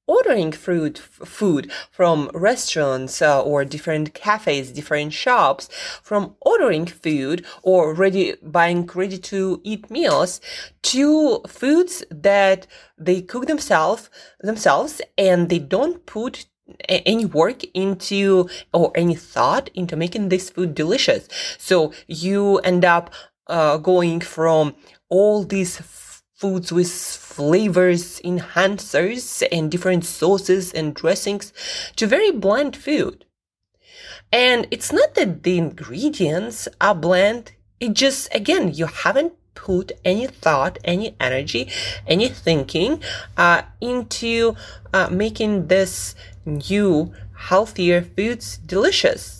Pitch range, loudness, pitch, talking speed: 170-225 Hz, -19 LUFS, 185 Hz, 115 wpm